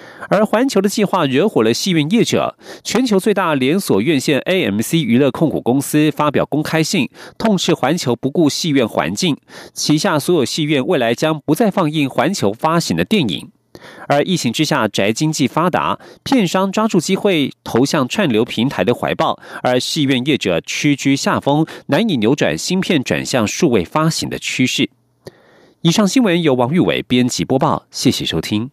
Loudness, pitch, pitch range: -16 LUFS, 155 Hz, 135-190 Hz